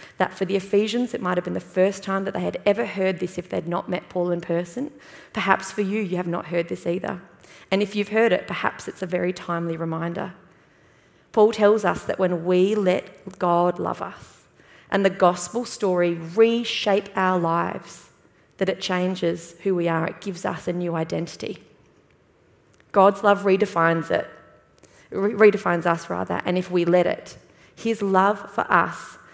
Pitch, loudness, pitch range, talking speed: 185 Hz, -23 LUFS, 175-200 Hz, 185 wpm